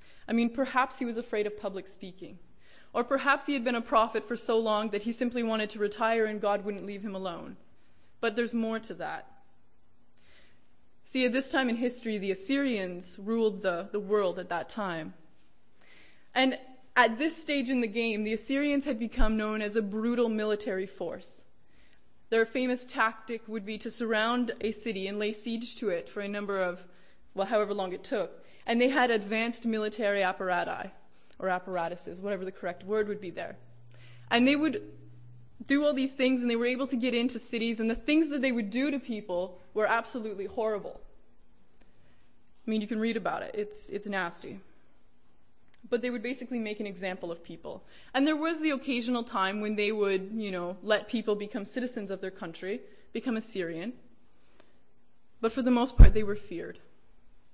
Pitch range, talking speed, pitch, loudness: 195-245 Hz, 190 wpm, 220 Hz, -30 LUFS